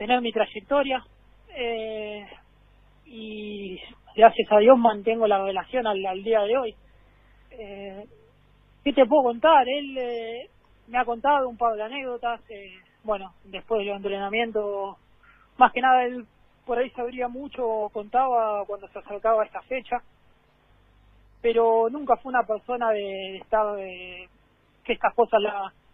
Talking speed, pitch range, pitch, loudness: 145 wpm, 205-245 Hz, 225 Hz, -24 LUFS